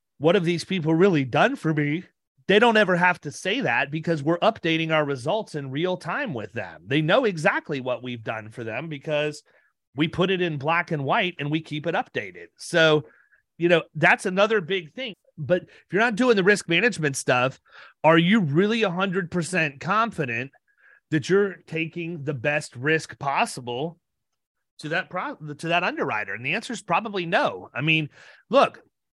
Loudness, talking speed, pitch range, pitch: -23 LUFS, 185 wpm, 150-190 Hz, 165 Hz